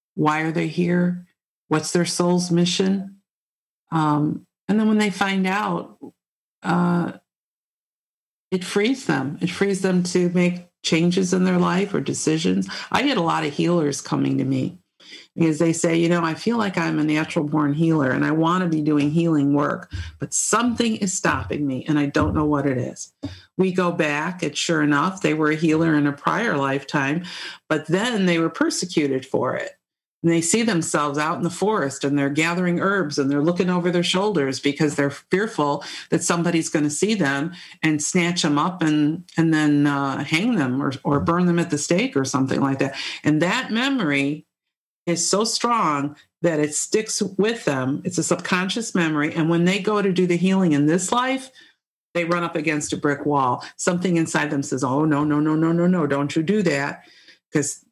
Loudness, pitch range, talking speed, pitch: -21 LUFS, 150-180 Hz, 195 wpm, 165 Hz